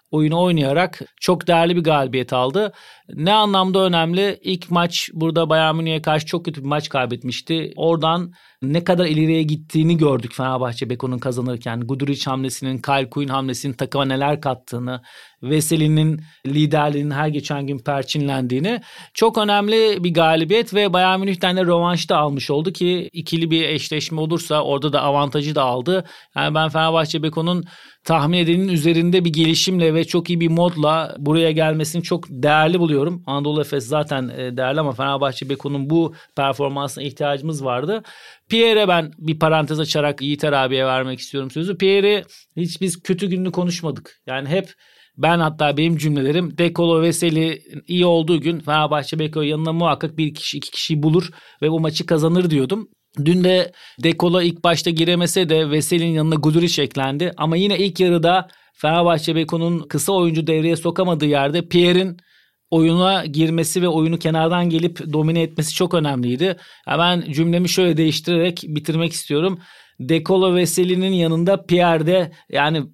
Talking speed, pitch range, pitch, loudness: 150 wpm, 145-175 Hz, 160 Hz, -19 LUFS